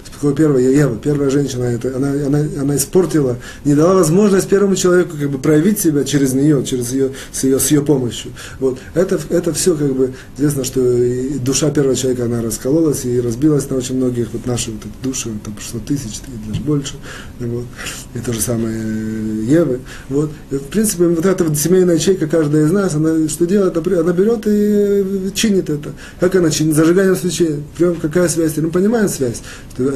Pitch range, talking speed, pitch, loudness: 125-170 Hz, 185 wpm, 145 Hz, -16 LUFS